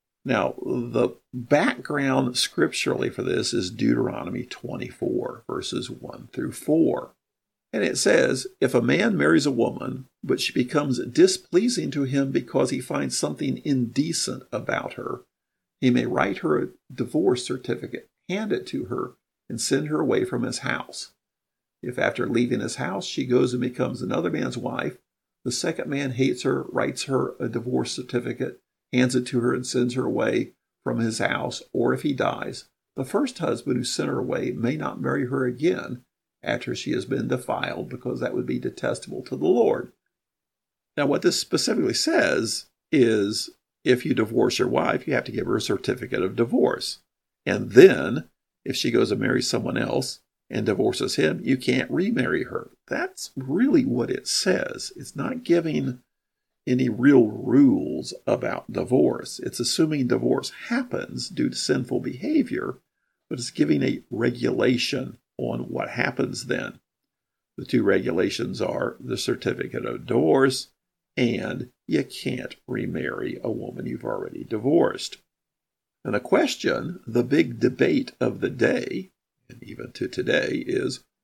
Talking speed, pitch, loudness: 155 wpm, 135 Hz, -24 LUFS